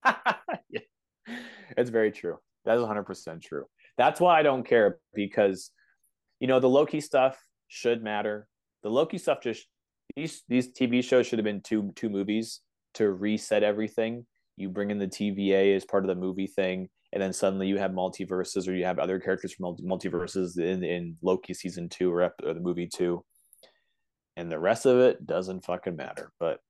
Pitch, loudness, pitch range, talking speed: 100 Hz, -28 LUFS, 95-110 Hz, 180 wpm